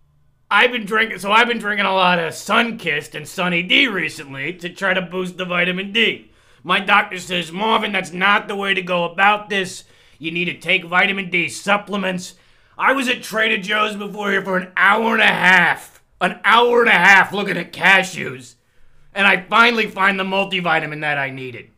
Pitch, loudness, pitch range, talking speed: 190 Hz, -16 LUFS, 175-205 Hz, 195 wpm